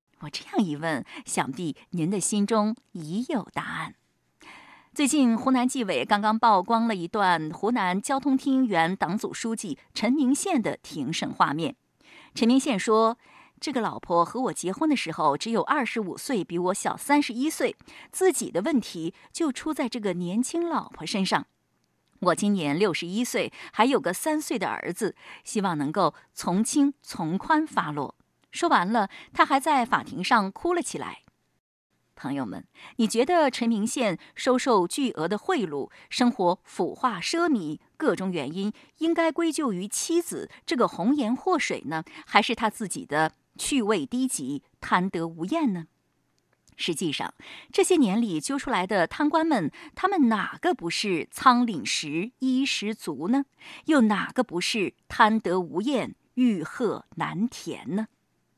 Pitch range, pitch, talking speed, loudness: 195-275 Hz, 235 Hz, 230 characters per minute, -26 LUFS